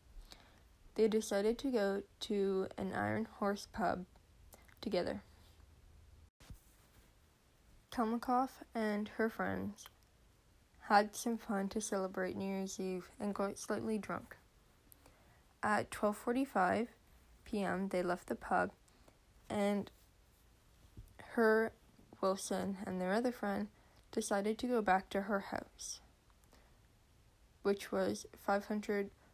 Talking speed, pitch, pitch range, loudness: 100 wpm, 200 Hz, 185-220 Hz, -38 LUFS